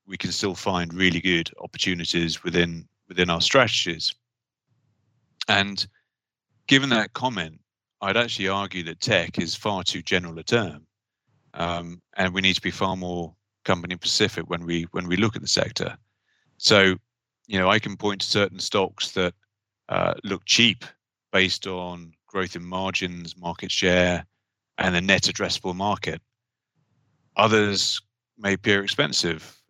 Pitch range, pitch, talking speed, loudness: 90-115 Hz, 95 Hz, 150 wpm, -23 LUFS